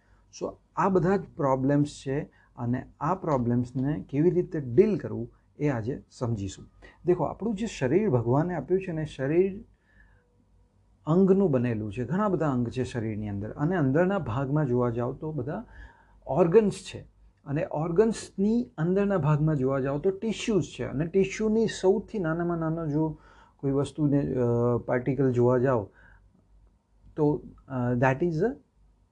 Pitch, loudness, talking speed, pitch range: 140 Hz, -27 LUFS, 140 wpm, 120-180 Hz